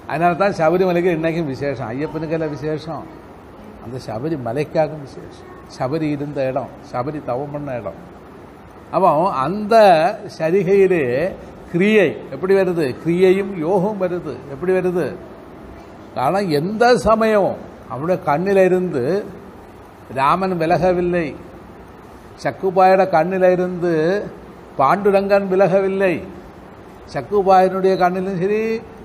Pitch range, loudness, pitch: 155-195 Hz, -18 LUFS, 180 Hz